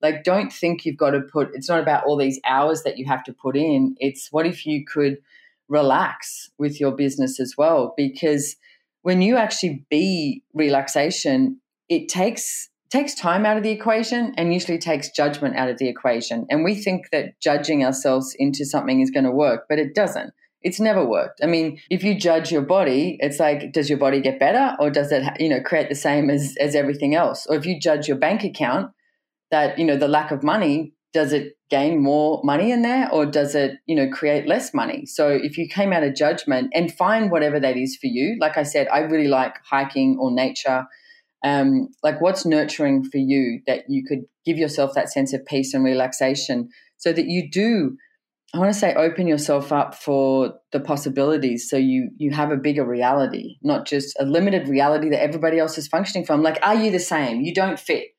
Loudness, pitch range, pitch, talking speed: -21 LUFS, 140-185 Hz, 150 Hz, 210 wpm